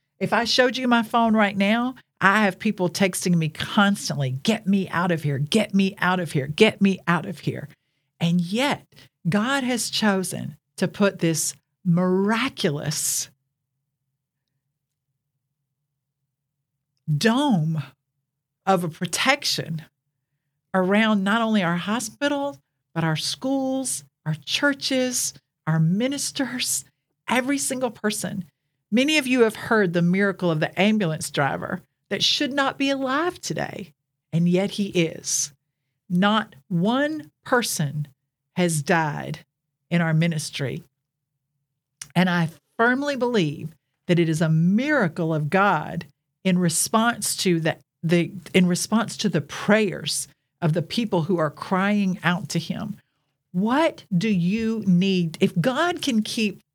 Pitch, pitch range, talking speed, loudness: 175 Hz, 145-210 Hz, 130 wpm, -23 LUFS